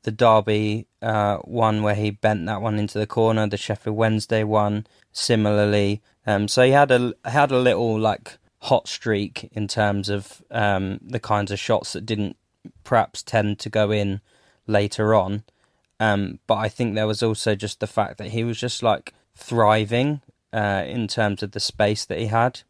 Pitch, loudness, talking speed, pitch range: 110 Hz, -22 LUFS, 190 wpm, 105-115 Hz